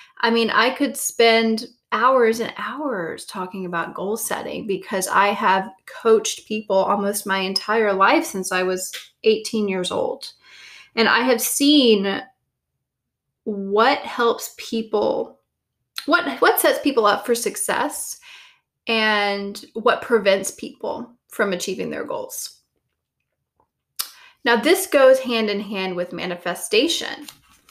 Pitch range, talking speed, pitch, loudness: 195-260 Hz, 125 wpm, 220 Hz, -20 LUFS